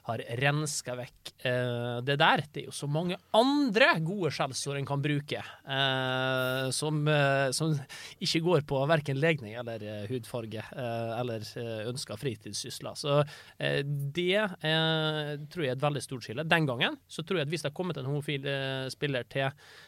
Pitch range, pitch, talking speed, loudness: 125-155 Hz, 140 Hz, 150 wpm, -30 LUFS